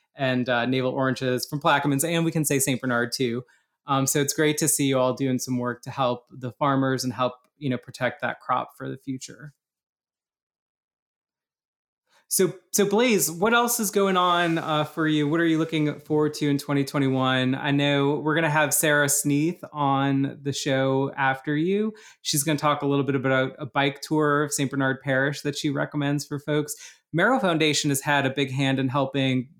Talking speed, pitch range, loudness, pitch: 195 wpm, 135-155 Hz, -24 LUFS, 140 Hz